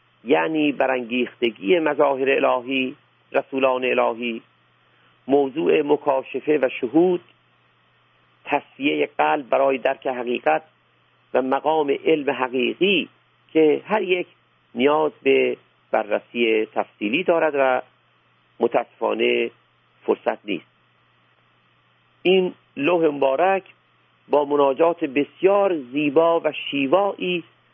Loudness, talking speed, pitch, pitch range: -21 LUFS, 85 wpm, 140 Hz, 125-165 Hz